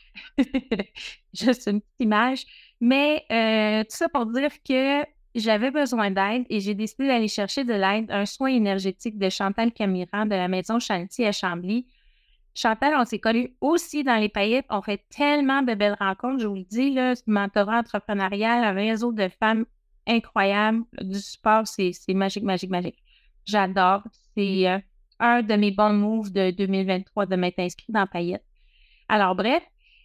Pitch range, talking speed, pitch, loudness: 200-240 Hz, 165 wpm, 215 Hz, -24 LUFS